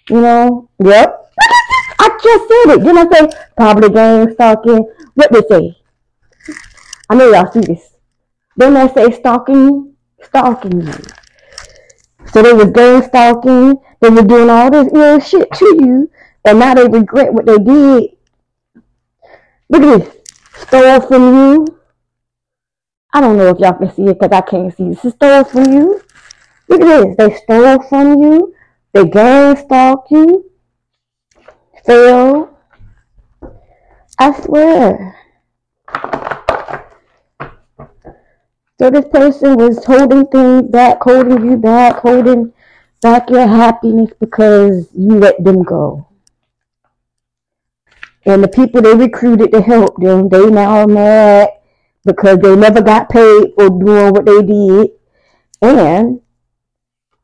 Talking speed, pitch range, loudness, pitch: 135 wpm, 210-275 Hz, -7 LUFS, 240 Hz